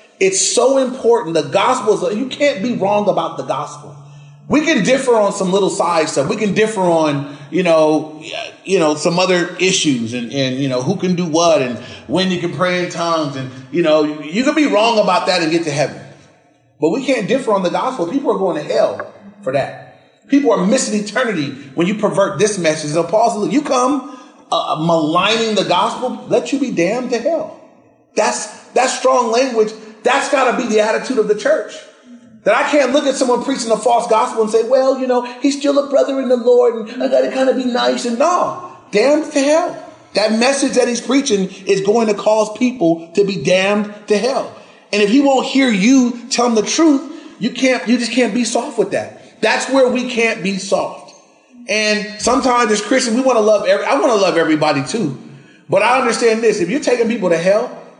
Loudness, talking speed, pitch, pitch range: -15 LUFS, 215 wpm, 220 Hz, 180-255 Hz